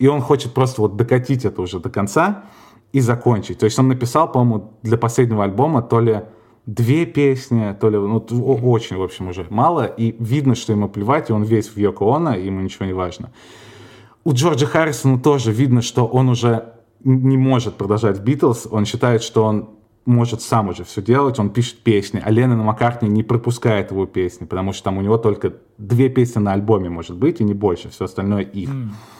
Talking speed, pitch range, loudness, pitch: 200 wpm, 105-125 Hz, -18 LUFS, 115 Hz